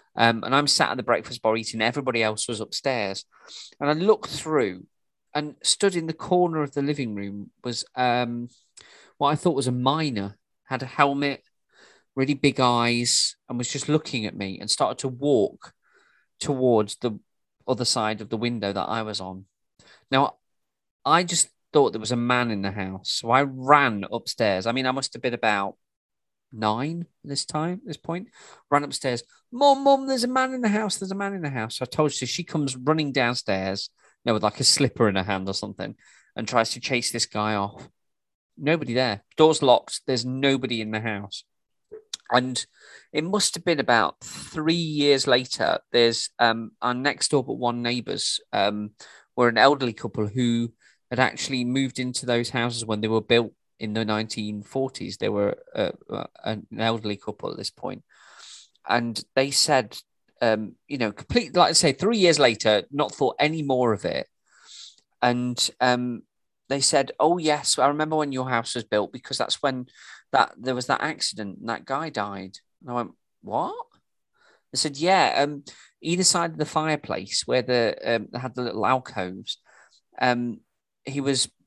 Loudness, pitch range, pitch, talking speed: -24 LUFS, 110-145 Hz, 125 Hz, 185 wpm